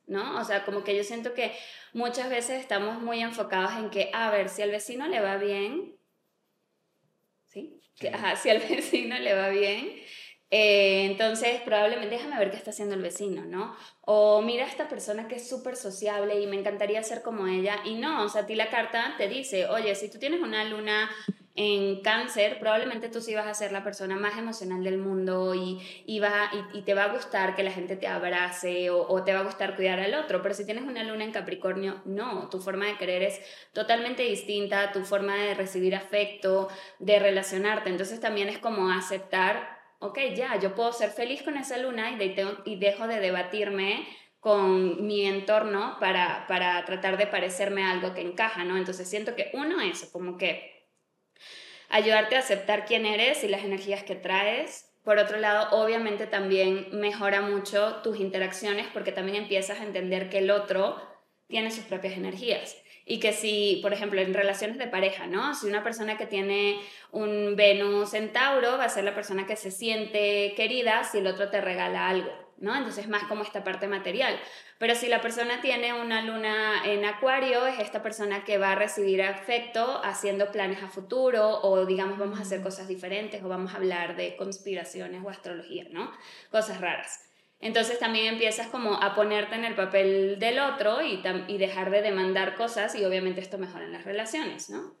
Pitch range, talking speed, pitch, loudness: 195-220 Hz, 195 wpm, 205 Hz, -28 LUFS